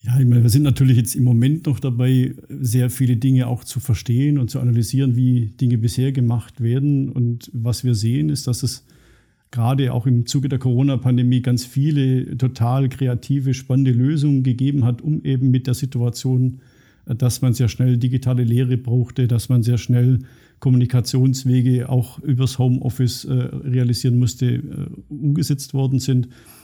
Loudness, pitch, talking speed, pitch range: -19 LUFS, 125 Hz, 160 wpm, 125-135 Hz